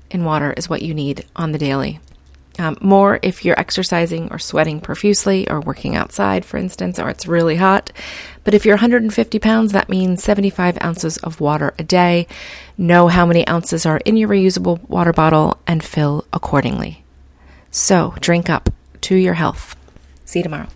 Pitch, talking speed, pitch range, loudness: 170 Hz, 175 wpm, 150-190 Hz, -16 LUFS